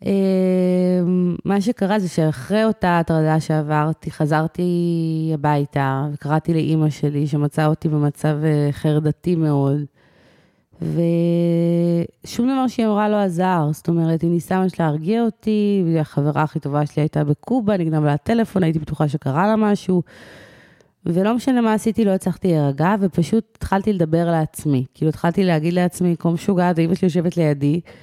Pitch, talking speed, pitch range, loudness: 170 Hz, 145 wpm, 155-190 Hz, -19 LUFS